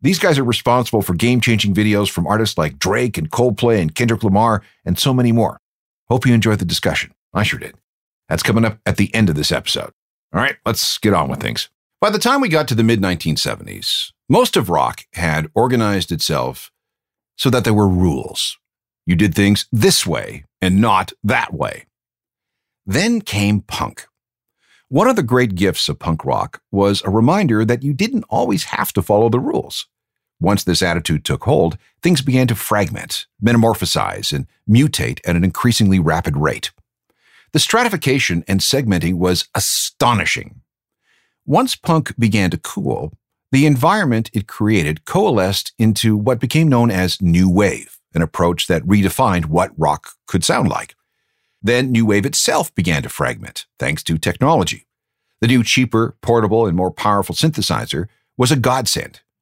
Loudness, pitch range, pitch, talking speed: -16 LUFS, 95-125 Hz, 110 Hz, 170 wpm